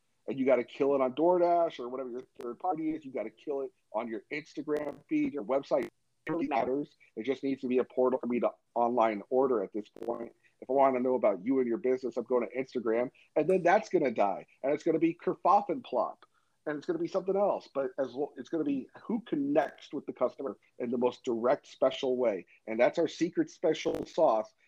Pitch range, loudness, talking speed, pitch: 125-165 Hz, -31 LUFS, 245 wpm, 135 Hz